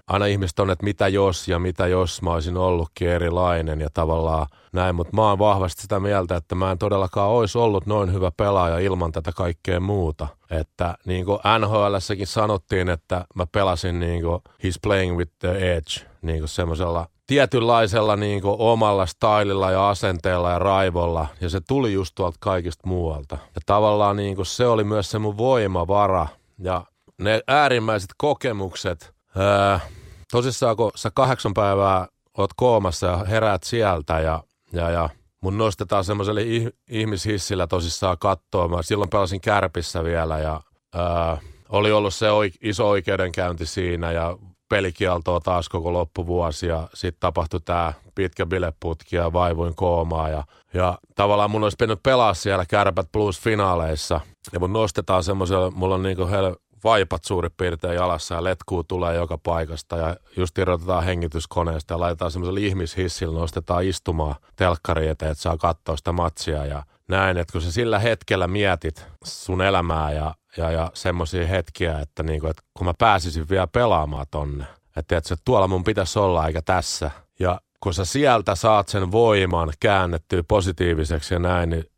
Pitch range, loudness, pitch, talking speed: 85-100 Hz, -22 LUFS, 90 Hz, 160 wpm